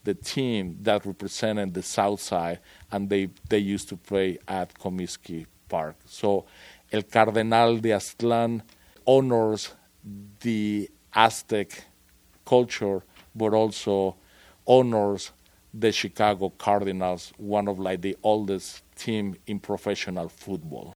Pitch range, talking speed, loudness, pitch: 95-110 Hz, 115 wpm, -26 LUFS, 100 Hz